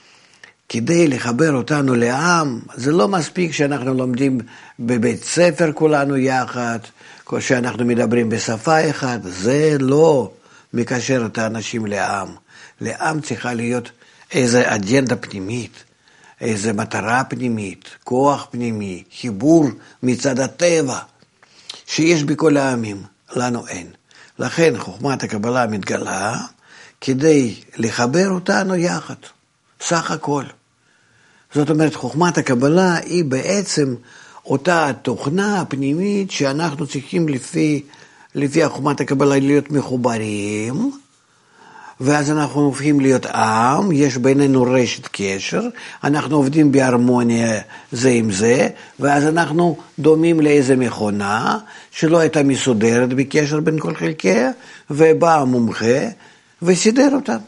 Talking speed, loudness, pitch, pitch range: 105 wpm, -17 LUFS, 140 Hz, 120-155 Hz